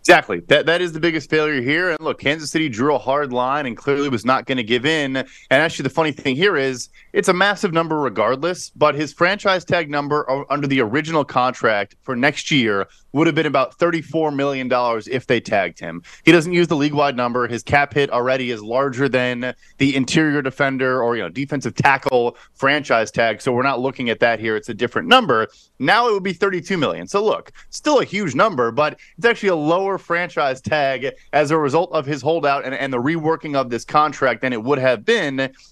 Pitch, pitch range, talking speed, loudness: 140 Hz, 130-160 Hz, 220 wpm, -19 LUFS